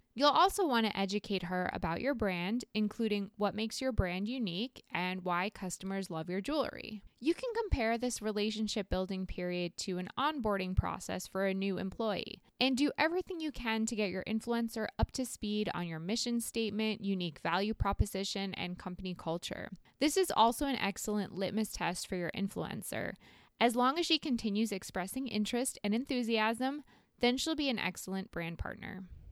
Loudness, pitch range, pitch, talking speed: -35 LUFS, 190-245 Hz, 210 Hz, 170 wpm